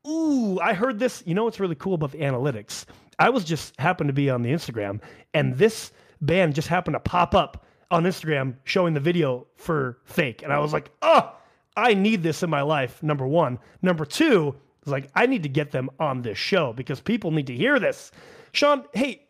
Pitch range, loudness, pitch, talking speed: 140-195 Hz, -24 LUFS, 160 Hz, 215 wpm